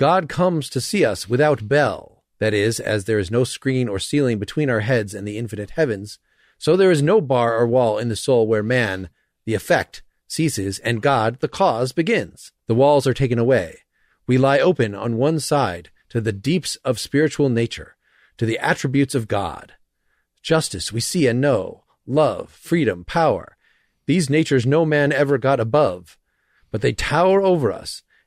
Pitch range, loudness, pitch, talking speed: 110-145 Hz, -20 LUFS, 130 Hz, 185 wpm